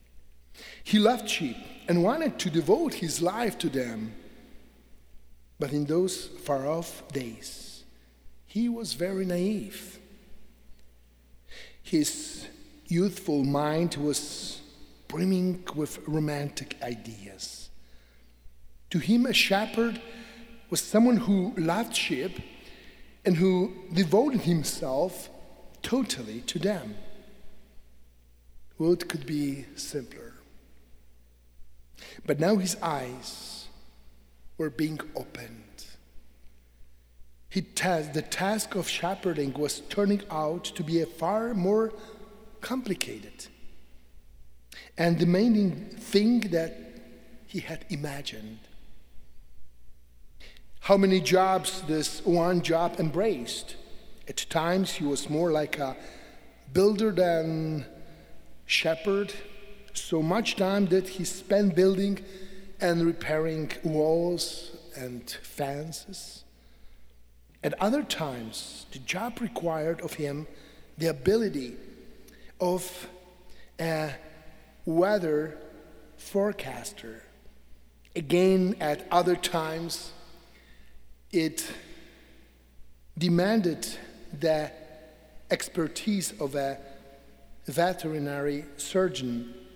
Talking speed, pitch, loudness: 90 wpm, 160 Hz, -28 LUFS